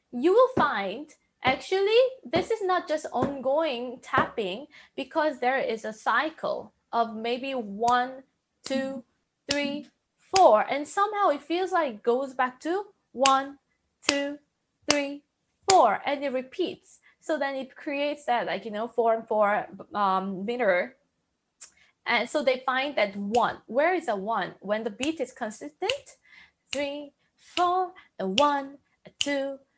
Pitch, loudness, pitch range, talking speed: 275 Hz, -27 LUFS, 245-310 Hz, 145 wpm